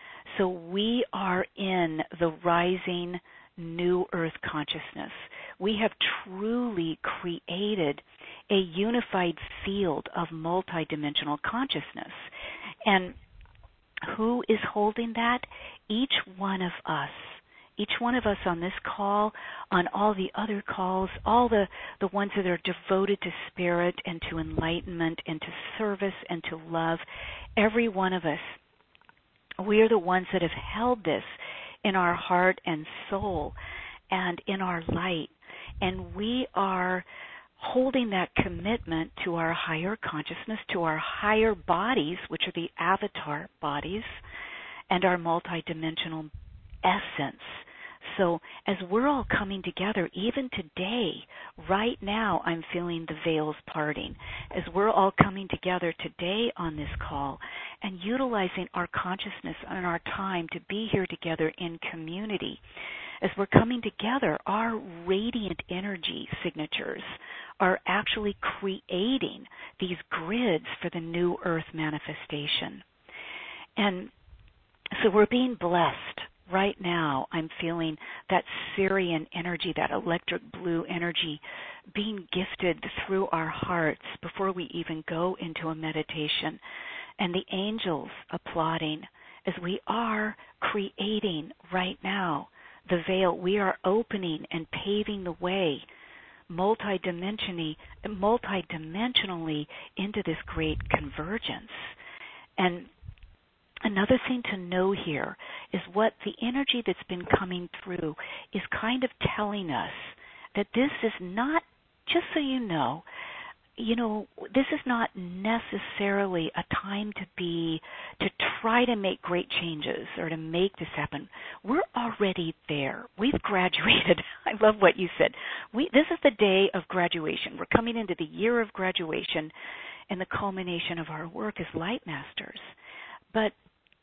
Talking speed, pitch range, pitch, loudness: 130 wpm, 170-210 Hz, 185 Hz, -29 LUFS